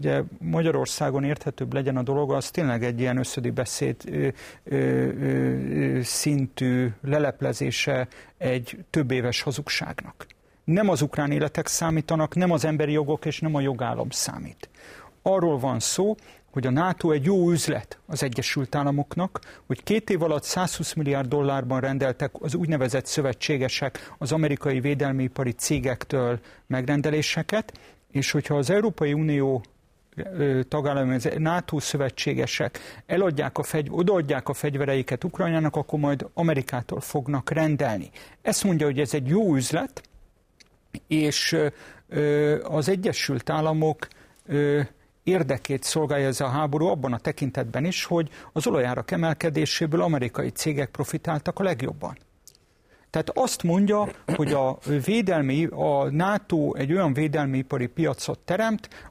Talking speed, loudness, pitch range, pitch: 125 wpm, -25 LUFS, 135-160 Hz, 150 Hz